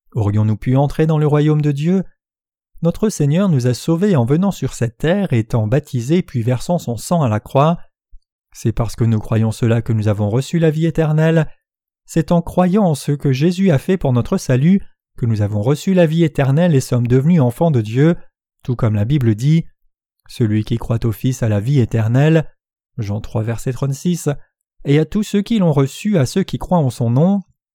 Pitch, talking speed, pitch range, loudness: 140 Hz, 210 wpm, 120-165 Hz, -16 LUFS